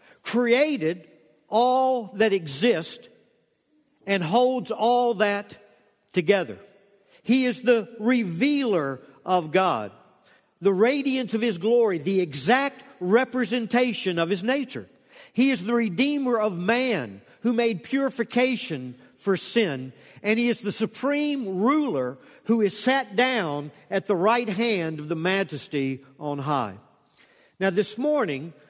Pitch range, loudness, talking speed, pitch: 180-245 Hz, -24 LUFS, 125 wpm, 220 Hz